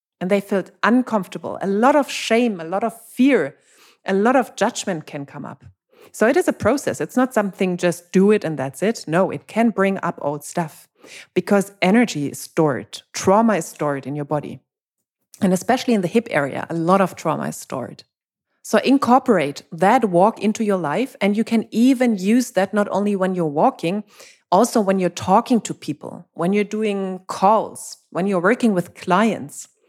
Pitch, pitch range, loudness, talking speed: 195 Hz, 175-230 Hz, -19 LUFS, 190 wpm